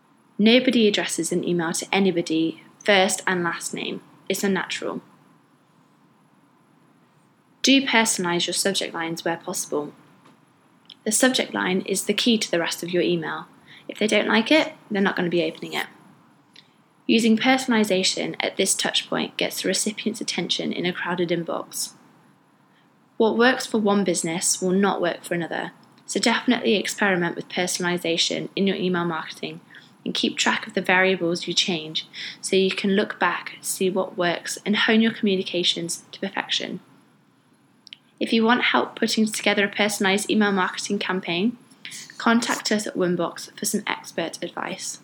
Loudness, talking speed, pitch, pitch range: -22 LUFS, 155 wpm, 195 Hz, 175-220 Hz